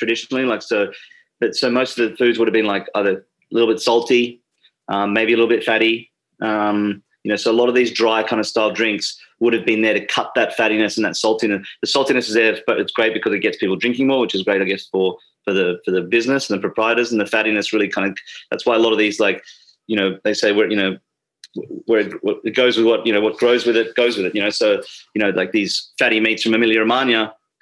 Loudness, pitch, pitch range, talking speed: -18 LUFS, 115 Hz, 105-120 Hz, 265 wpm